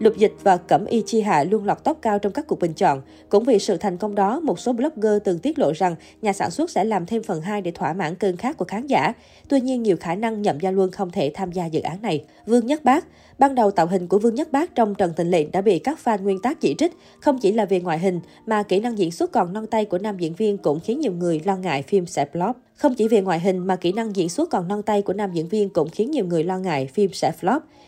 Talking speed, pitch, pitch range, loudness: 295 wpm, 200 Hz, 180-230 Hz, -22 LUFS